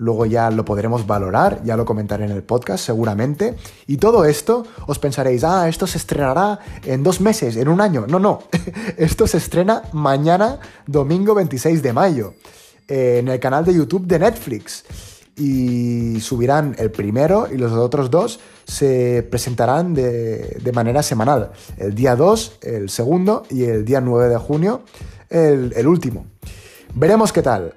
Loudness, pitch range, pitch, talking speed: -17 LUFS, 115-165 Hz, 130 Hz, 160 wpm